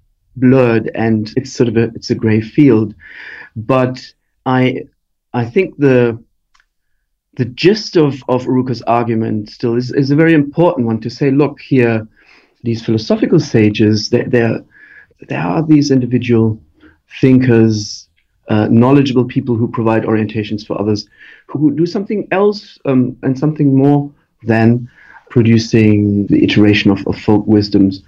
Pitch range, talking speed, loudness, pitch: 110-135 Hz, 145 wpm, -13 LUFS, 120 Hz